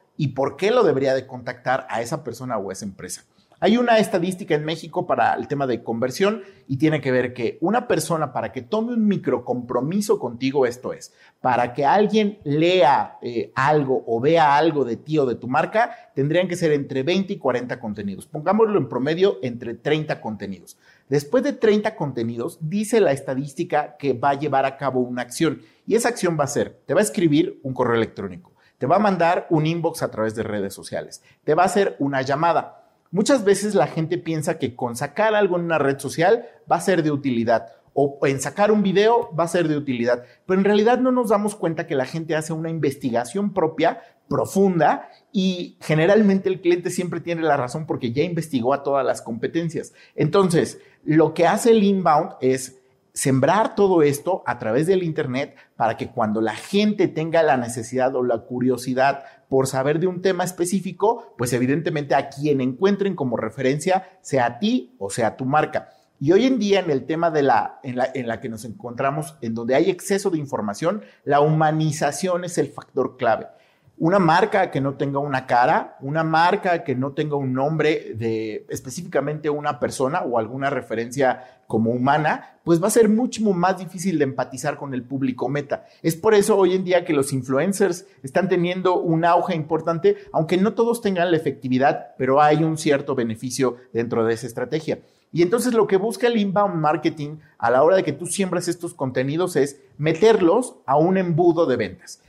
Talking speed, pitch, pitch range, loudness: 195 wpm, 155 Hz, 130-185 Hz, -21 LUFS